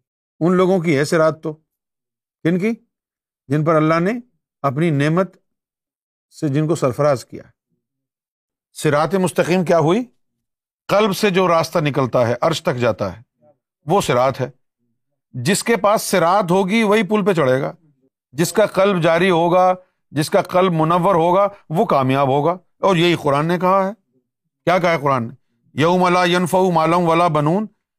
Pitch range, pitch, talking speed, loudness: 140-185 Hz, 165 Hz, 165 wpm, -17 LUFS